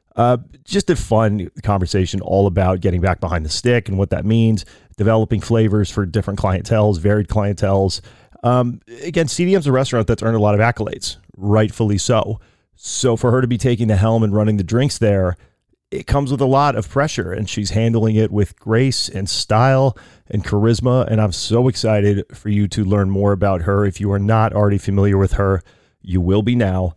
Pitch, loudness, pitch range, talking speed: 105 Hz, -17 LUFS, 100-120 Hz, 200 wpm